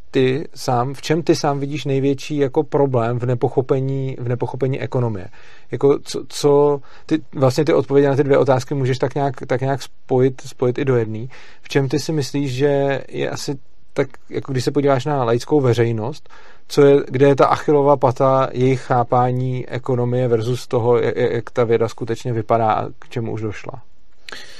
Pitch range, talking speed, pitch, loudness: 125-145 Hz, 185 wpm, 135 Hz, -19 LUFS